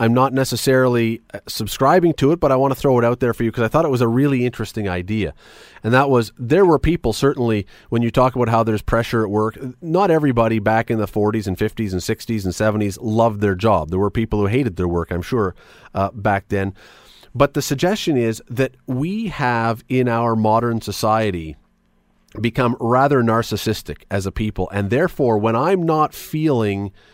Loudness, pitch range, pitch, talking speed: -19 LUFS, 105-130 Hz, 115 Hz, 200 wpm